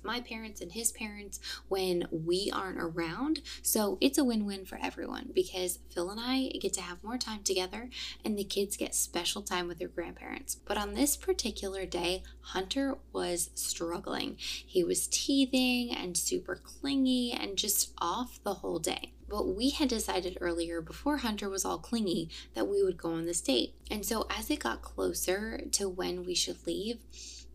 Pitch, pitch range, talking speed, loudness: 200 Hz, 180-245 Hz, 180 wpm, -33 LUFS